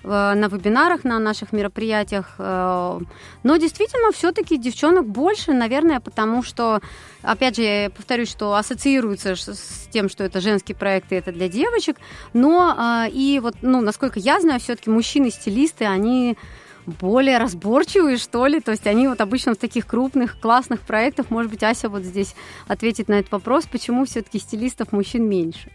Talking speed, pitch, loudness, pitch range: 155 wpm, 230 Hz, -20 LUFS, 210-265 Hz